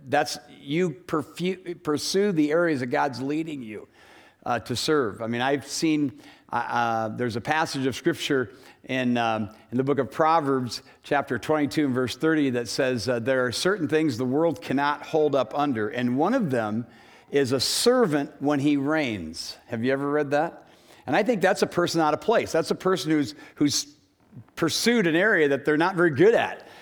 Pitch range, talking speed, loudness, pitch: 125-155 Hz, 195 wpm, -24 LUFS, 145 Hz